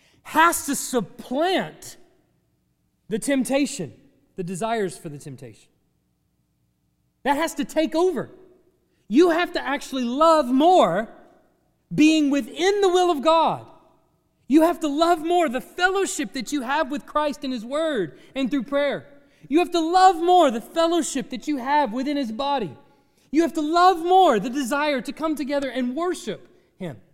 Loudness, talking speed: -22 LUFS, 155 wpm